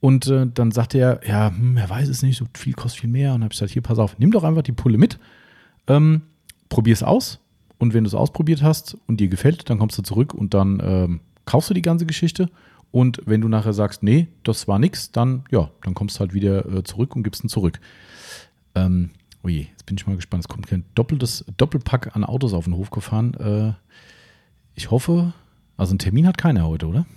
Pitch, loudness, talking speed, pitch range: 115 Hz, -20 LUFS, 230 wpm, 100-135 Hz